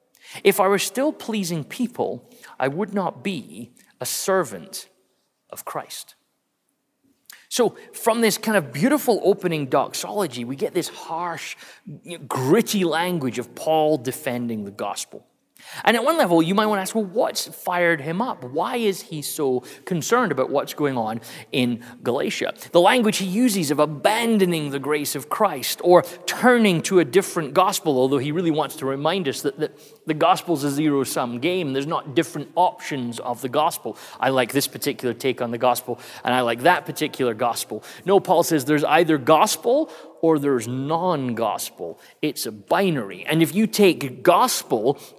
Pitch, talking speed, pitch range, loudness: 160 Hz, 170 wpm, 135-190 Hz, -22 LUFS